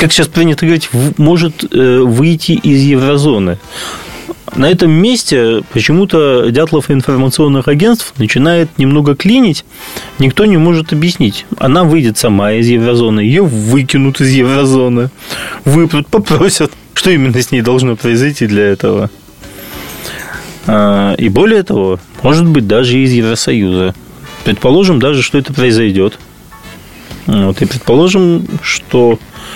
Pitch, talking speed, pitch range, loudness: 135 Hz, 125 wpm, 120-165 Hz, -10 LUFS